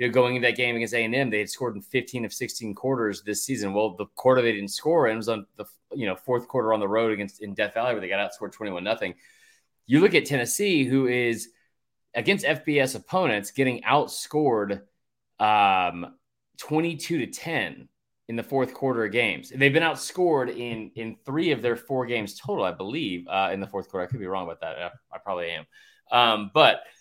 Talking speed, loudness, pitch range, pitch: 215 wpm, -25 LUFS, 110-135 Hz, 120 Hz